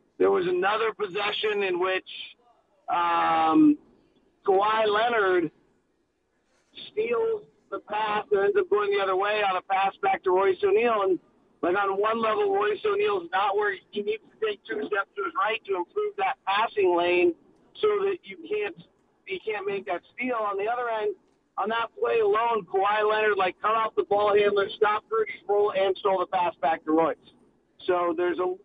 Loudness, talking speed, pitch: -25 LUFS, 185 wpm, 225 Hz